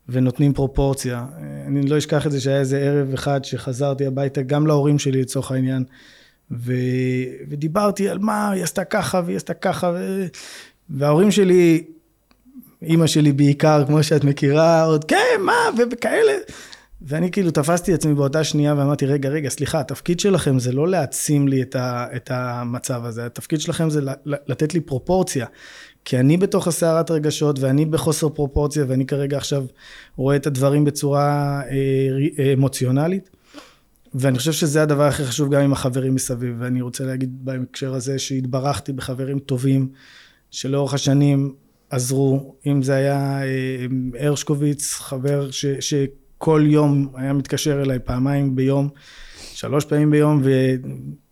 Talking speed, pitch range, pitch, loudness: 140 wpm, 135-155 Hz, 140 Hz, -20 LUFS